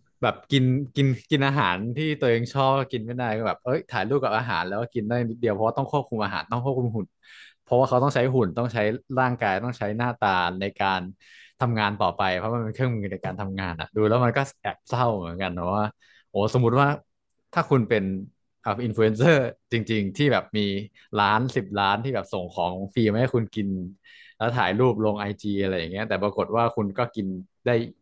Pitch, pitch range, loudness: 115 Hz, 100-125 Hz, -25 LUFS